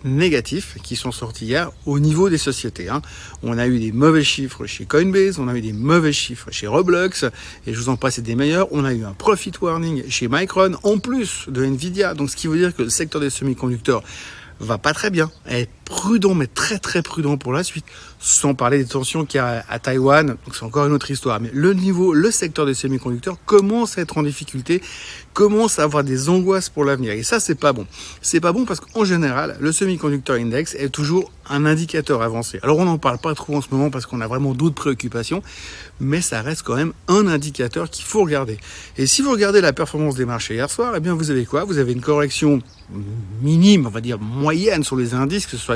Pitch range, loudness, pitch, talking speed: 125-165 Hz, -19 LUFS, 145 Hz, 235 wpm